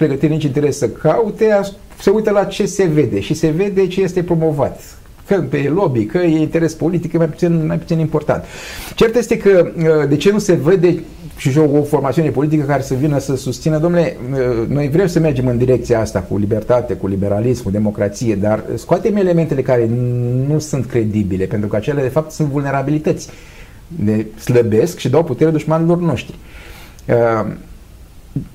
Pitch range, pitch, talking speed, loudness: 125-170 Hz, 150 Hz, 170 wpm, -16 LUFS